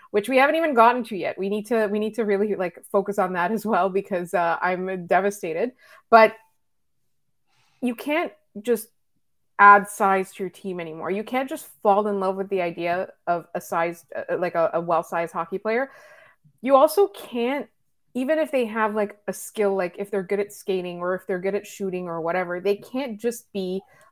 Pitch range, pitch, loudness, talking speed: 185-230 Hz, 200 Hz, -23 LUFS, 200 wpm